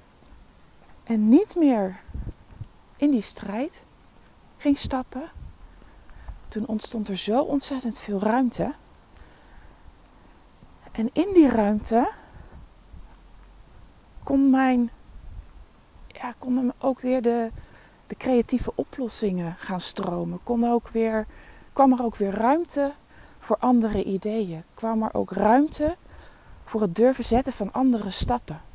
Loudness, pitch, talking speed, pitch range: -24 LUFS, 225 Hz, 110 wpm, 195-260 Hz